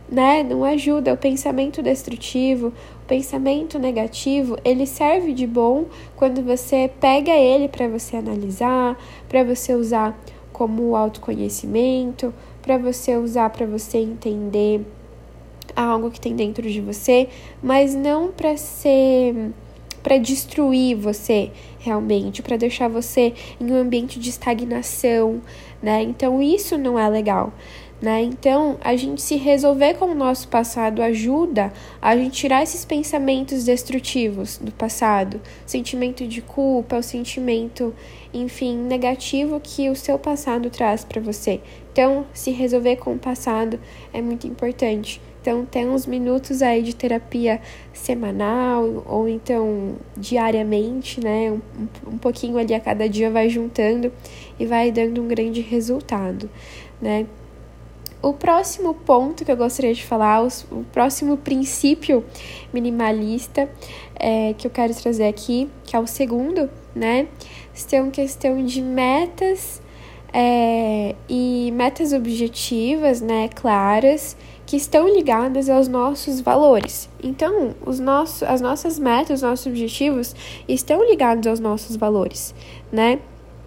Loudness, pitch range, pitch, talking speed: -20 LUFS, 225-270 Hz, 245 Hz, 130 wpm